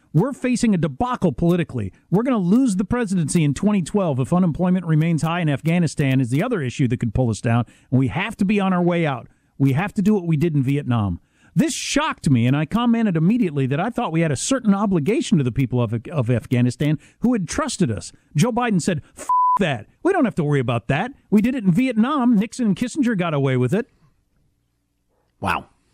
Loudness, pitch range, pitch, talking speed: -20 LUFS, 135-215 Hz, 170 Hz, 220 wpm